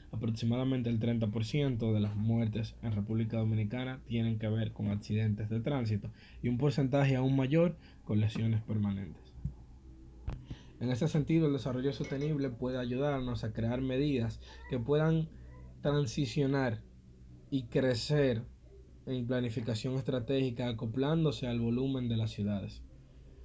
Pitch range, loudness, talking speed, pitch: 110-135 Hz, -33 LUFS, 125 wpm, 120 Hz